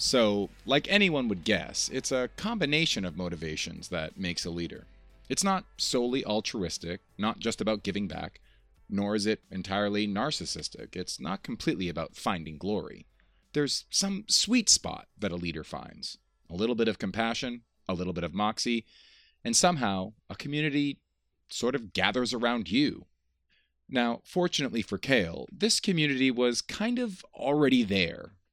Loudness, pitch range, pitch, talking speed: -29 LUFS, 100-155 Hz, 120 Hz, 150 wpm